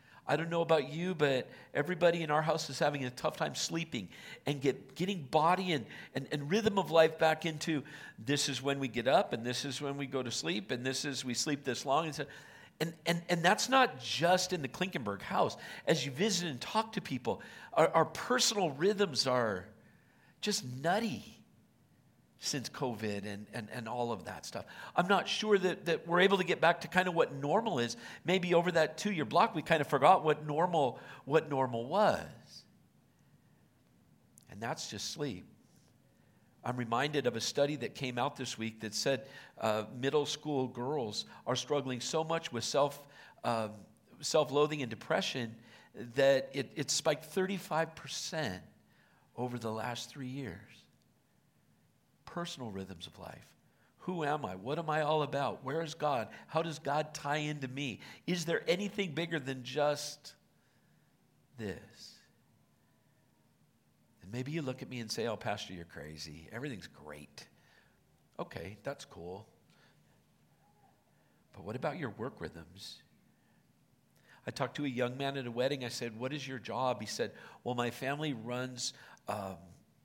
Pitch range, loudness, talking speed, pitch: 125-160 Hz, -34 LUFS, 170 wpm, 145 Hz